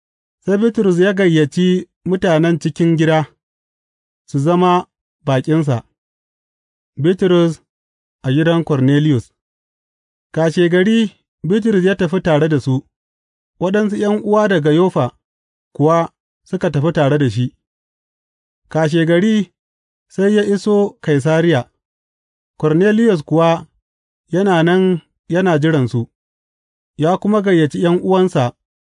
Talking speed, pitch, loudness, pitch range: 100 wpm, 165 Hz, -15 LUFS, 130-185 Hz